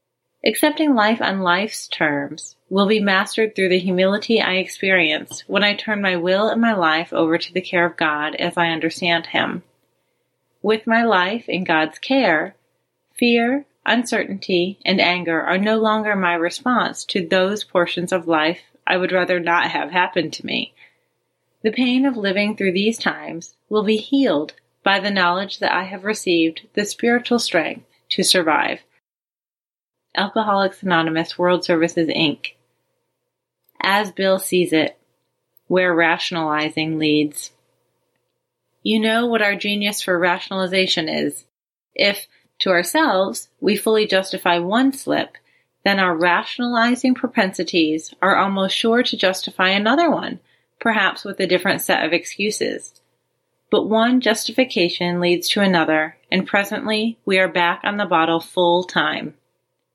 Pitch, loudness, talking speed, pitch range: 190 Hz, -19 LUFS, 145 wpm, 175-215 Hz